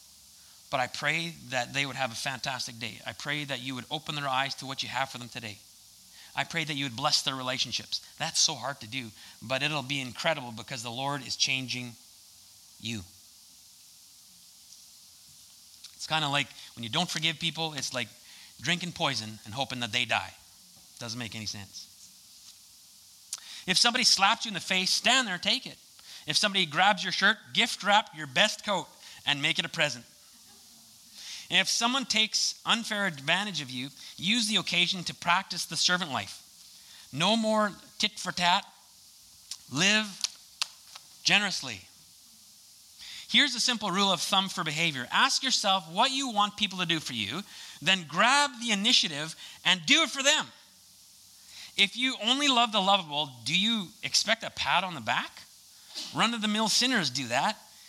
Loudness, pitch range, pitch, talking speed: -27 LUFS, 125-200 Hz, 160 Hz, 175 wpm